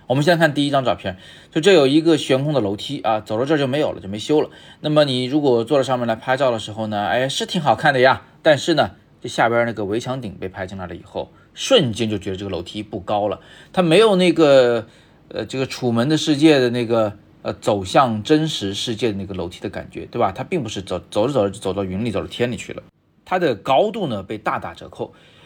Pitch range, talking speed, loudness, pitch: 105-145 Hz, 350 characters per minute, -19 LUFS, 120 Hz